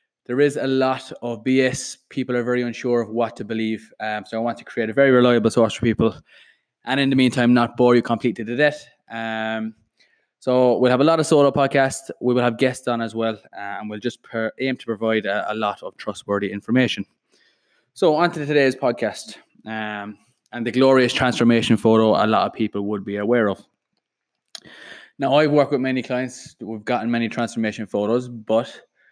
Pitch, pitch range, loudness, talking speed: 120 Hz, 110-130 Hz, -20 LUFS, 200 wpm